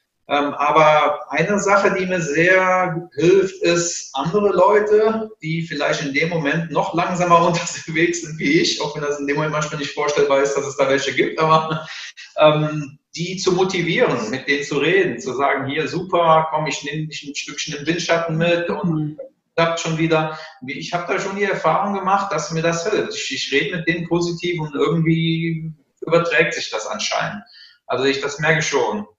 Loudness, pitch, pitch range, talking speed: -19 LUFS, 165 Hz, 150-175 Hz, 185 wpm